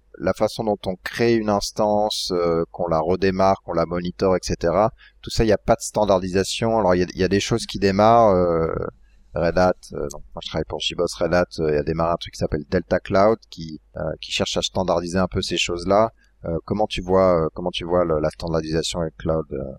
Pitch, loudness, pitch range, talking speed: 90 Hz, -21 LUFS, 85-100 Hz, 235 wpm